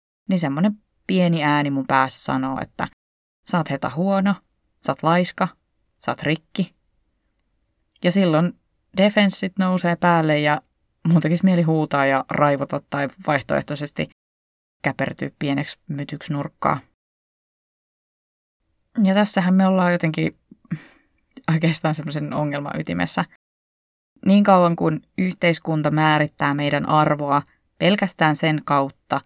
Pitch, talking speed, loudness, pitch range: 155 Hz, 110 wpm, -21 LUFS, 145-180 Hz